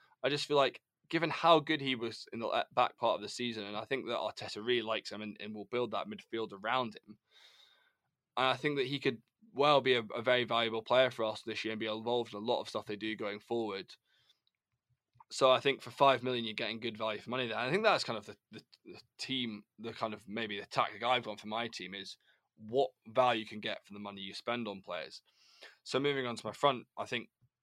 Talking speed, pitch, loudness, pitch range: 250 wpm, 115 Hz, -34 LUFS, 110-130 Hz